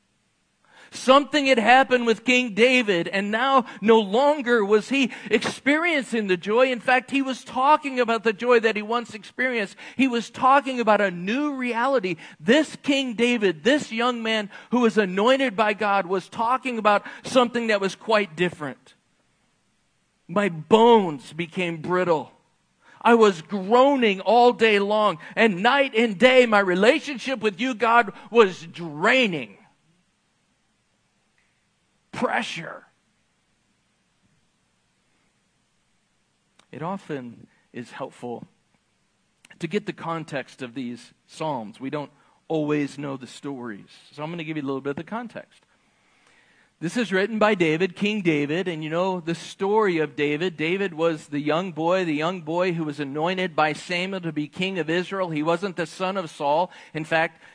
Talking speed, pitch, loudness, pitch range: 150 wpm, 205 Hz, -22 LUFS, 170-240 Hz